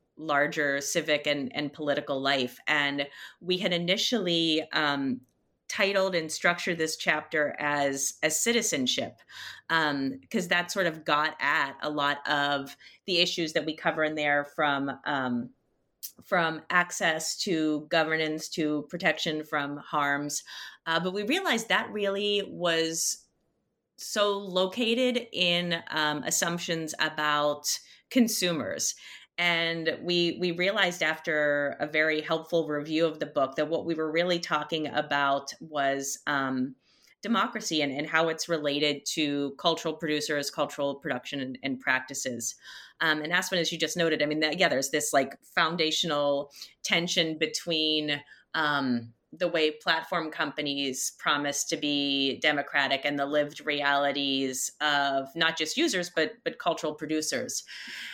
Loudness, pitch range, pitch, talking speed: -28 LUFS, 145-170 Hz, 155 Hz, 135 wpm